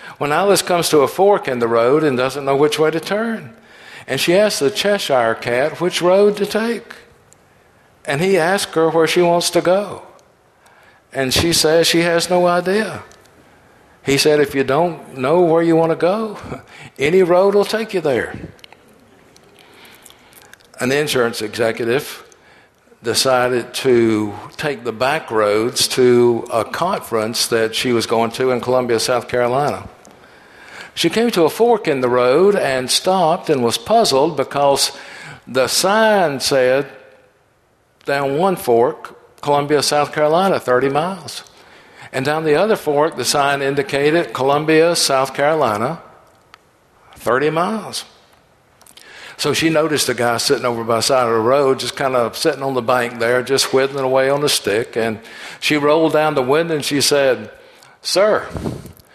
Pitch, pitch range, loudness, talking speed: 145 Hz, 125-170 Hz, -16 LUFS, 155 wpm